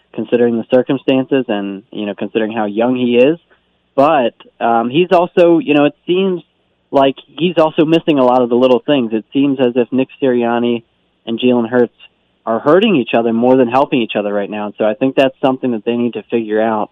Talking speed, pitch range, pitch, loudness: 215 wpm, 115-140 Hz, 125 Hz, -14 LUFS